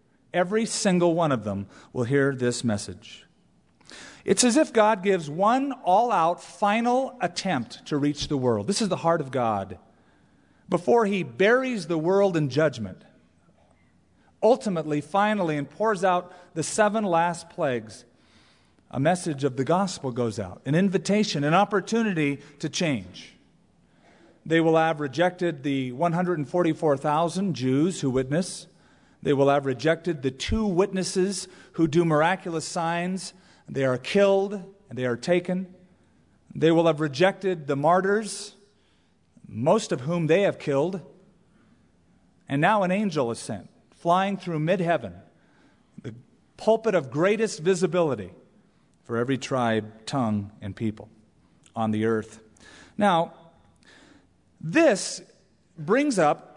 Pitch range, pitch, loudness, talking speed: 135-190 Hz, 165 Hz, -24 LUFS, 130 wpm